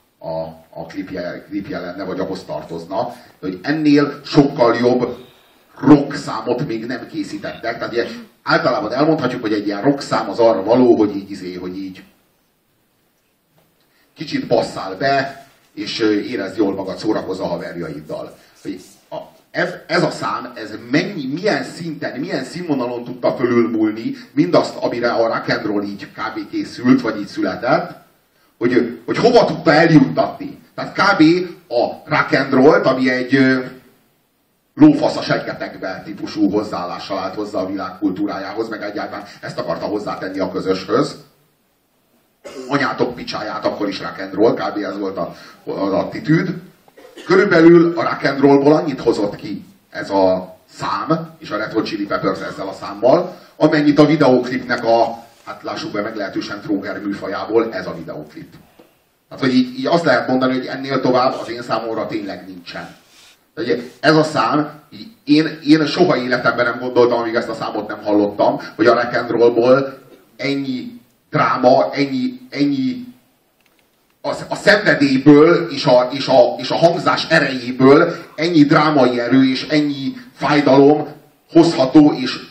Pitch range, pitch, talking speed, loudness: 120-160 Hz, 140 Hz, 140 wpm, -17 LUFS